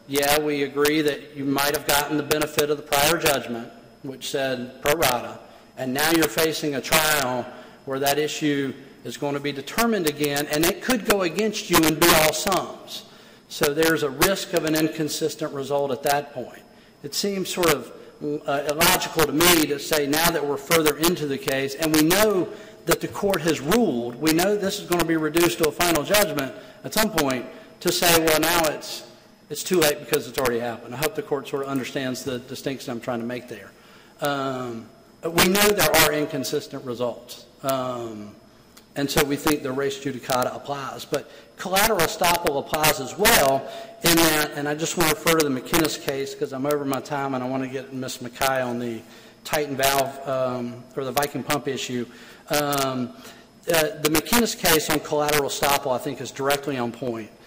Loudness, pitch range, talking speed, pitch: -22 LUFS, 135-160 Hz, 200 wpm, 145 Hz